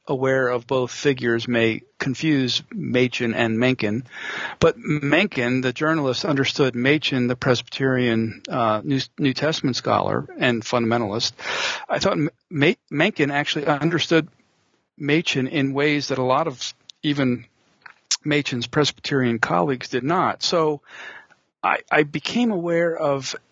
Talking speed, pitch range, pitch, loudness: 130 wpm, 125-150 Hz, 135 Hz, -22 LUFS